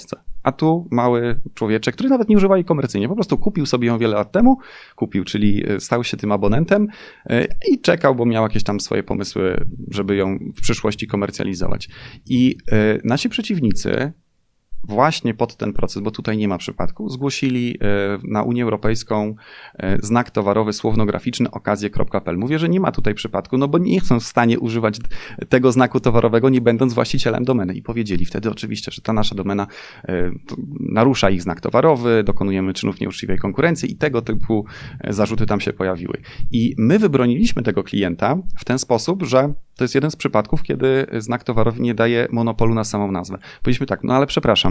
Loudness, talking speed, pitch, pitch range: -19 LUFS, 170 wpm, 115 Hz, 105-130 Hz